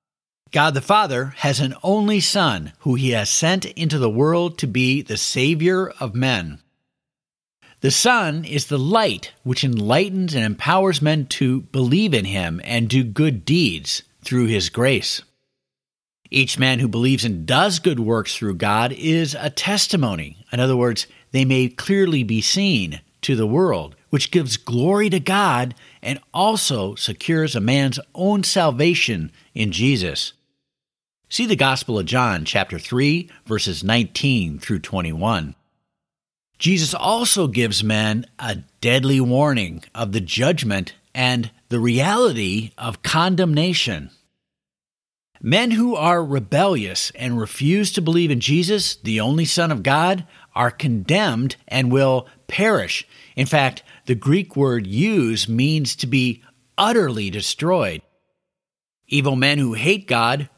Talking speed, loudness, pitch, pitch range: 140 wpm, -19 LUFS, 135 Hz, 115-165 Hz